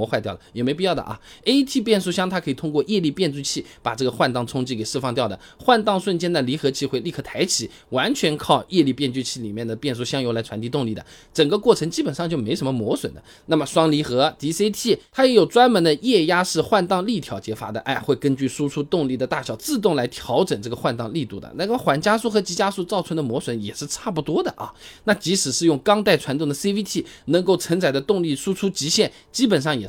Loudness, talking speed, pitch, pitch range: -21 LUFS, 365 characters per minute, 155 Hz, 135-195 Hz